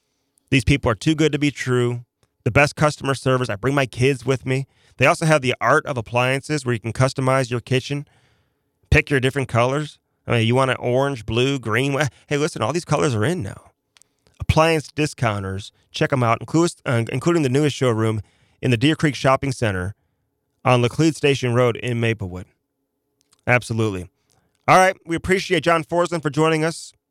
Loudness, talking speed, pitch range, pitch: -20 LUFS, 185 wpm, 120-145 Hz, 135 Hz